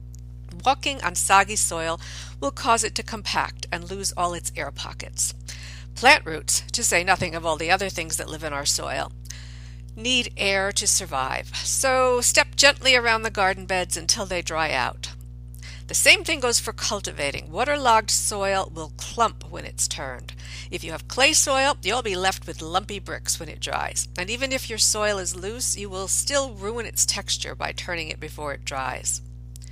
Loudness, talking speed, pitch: -22 LUFS, 185 wpm, 80 Hz